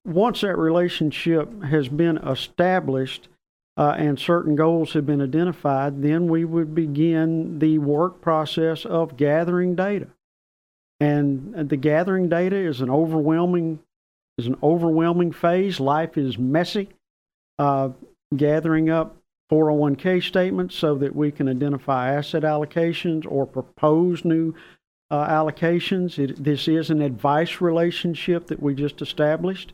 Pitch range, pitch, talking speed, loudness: 145-170 Hz, 160 Hz, 130 wpm, -22 LUFS